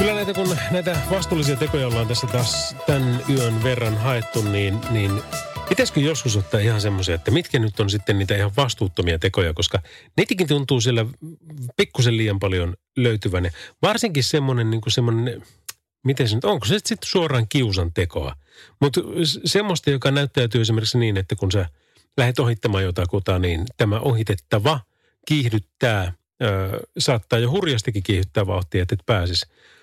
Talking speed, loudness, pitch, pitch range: 155 wpm, -21 LUFS, 115 Hz, 100-140 Hz